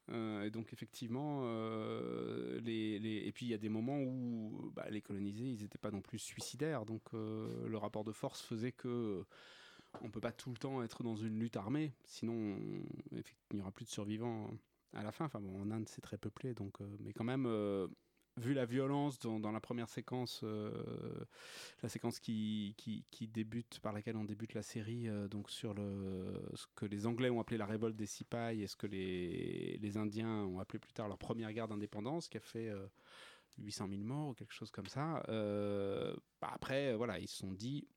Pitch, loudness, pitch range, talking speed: 110 Hz, -43 LUFS, 105-120 Hz, 215 wpm